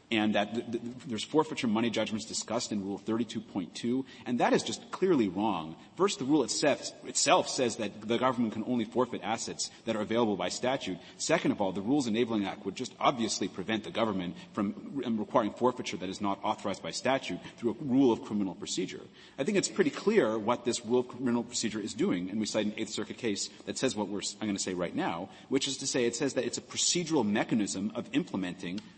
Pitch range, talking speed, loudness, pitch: 105-120 Hz, 225 wpm, -31 LUFS, 110 Hz